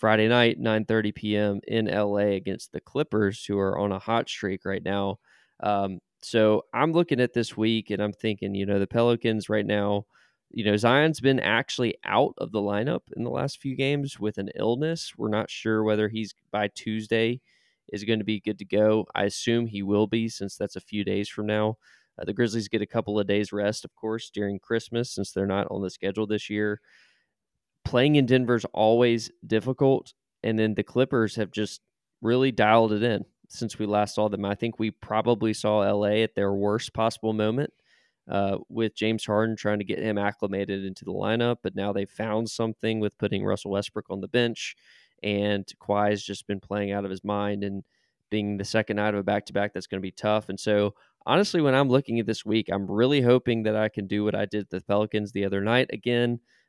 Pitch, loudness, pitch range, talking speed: 105 Hz, -26 LUFS, 100-115 Hz, 215 wpm